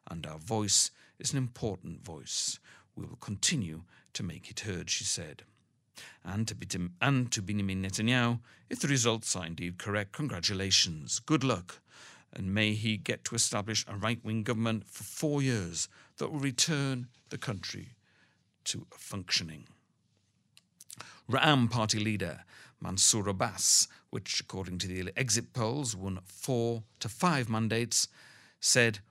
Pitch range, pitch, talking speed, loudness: 95-125 Hz, 110 Hz, 145 wpm, -31 LUFS